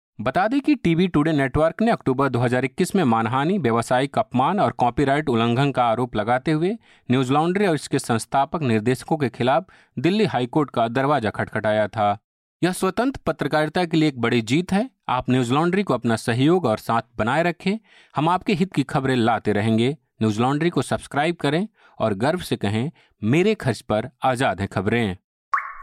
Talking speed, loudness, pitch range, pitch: 175 wpm, -22 LUFS, 115-170 Hz, 135 Hz